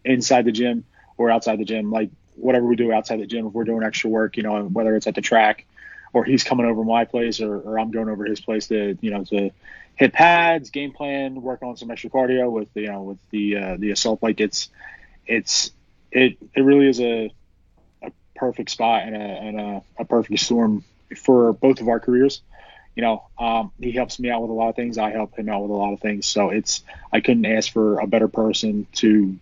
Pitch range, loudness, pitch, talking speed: 105-120 Hz, -21 LUFS, 110 Hz, 235 wpm